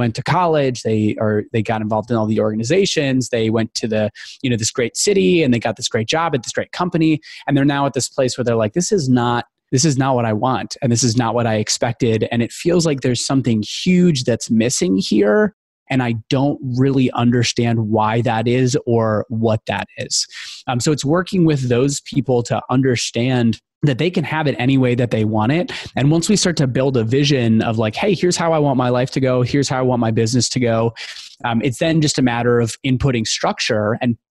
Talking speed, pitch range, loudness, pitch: 235 wpm, 115-140 Hz, -17 LUFS, 125 Hz